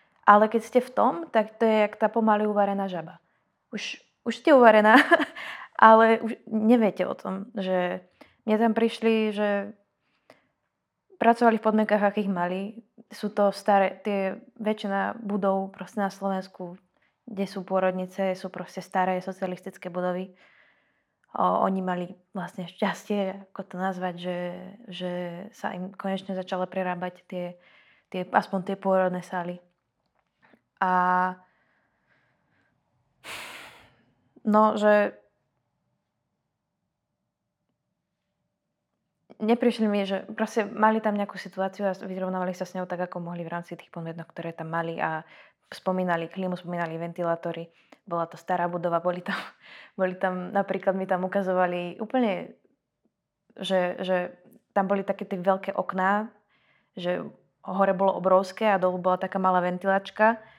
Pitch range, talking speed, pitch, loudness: 180-210 Hz, 130 wpm, 190 Hz, -26 LUFS